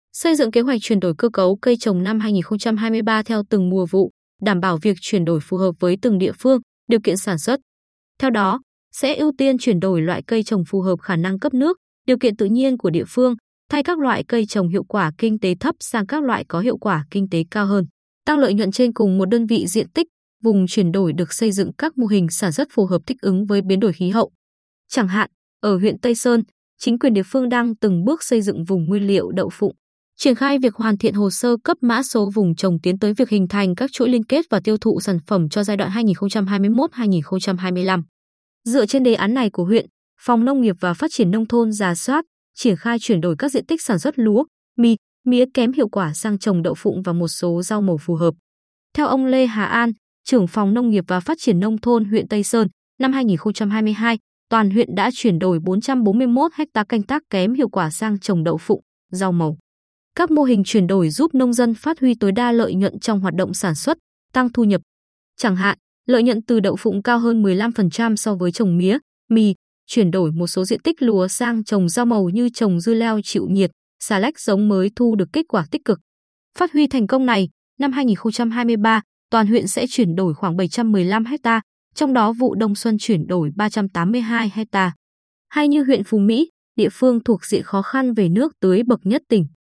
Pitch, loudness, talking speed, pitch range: 215 Hz, -19 LUFS, 225 wpm, 190-245 Hz